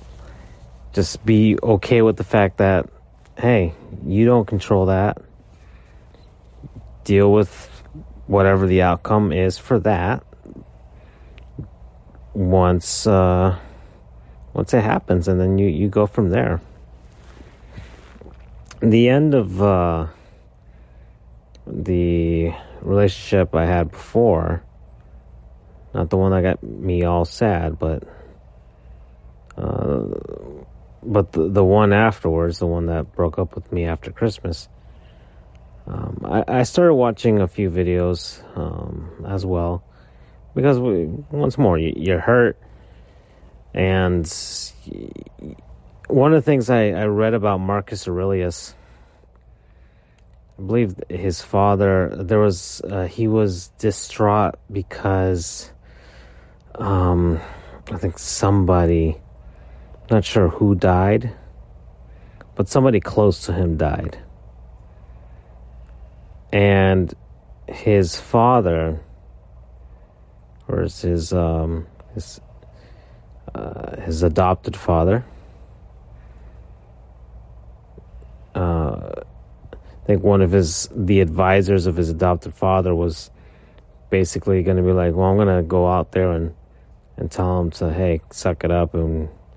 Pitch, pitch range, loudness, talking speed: 90 Hz, 75-100 Hz, -19 LUFS, 110 wpm